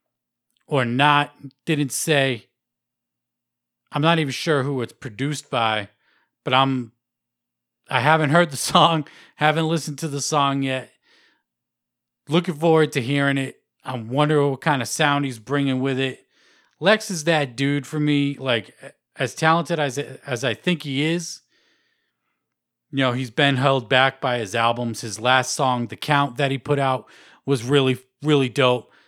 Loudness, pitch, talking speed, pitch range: -21 LUFS, 140 Hz, 160 wpm, 125-150 Hz